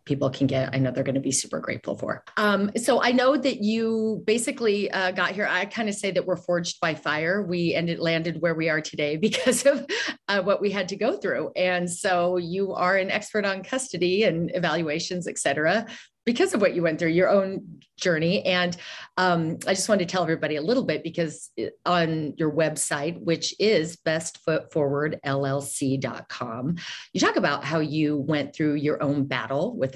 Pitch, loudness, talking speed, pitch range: 175 Hz, -25 LUFS, 195 wpm, 155-200 Hz